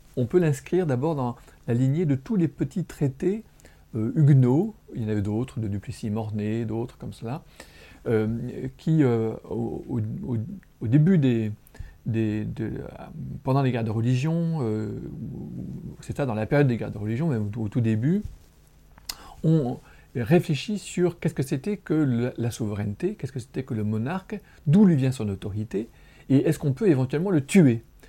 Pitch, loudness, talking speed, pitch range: 130 Hz, -25 LUFS, 170 wpm, 115-160 Hz